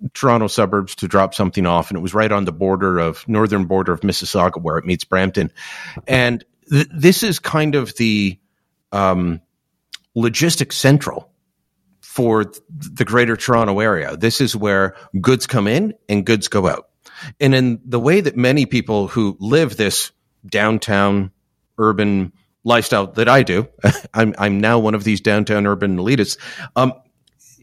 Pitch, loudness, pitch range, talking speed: 110 Hz, -17 LUFS, 100-130 Hz, 160 wpm